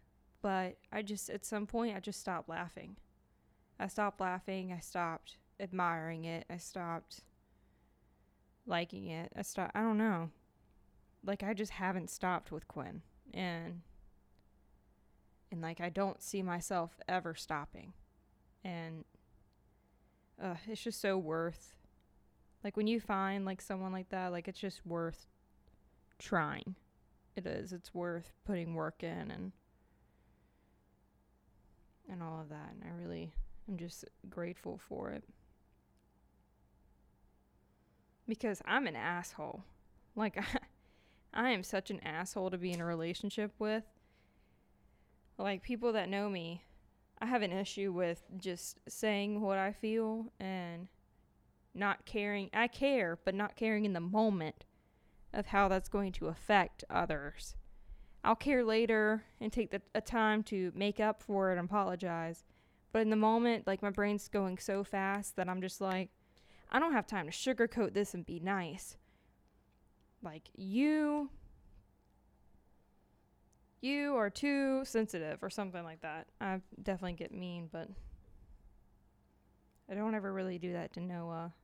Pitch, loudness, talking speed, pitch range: 190 Hz, -38 LUFS, 140 wpm, 170-215 Hz